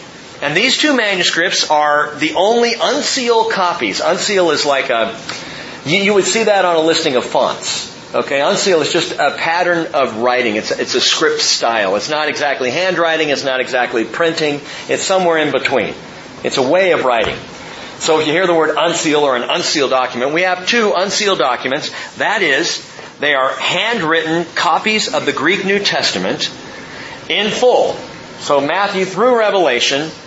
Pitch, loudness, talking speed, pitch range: 165 Hz, -14 LUFS, 170 wpm, 150-200 Hz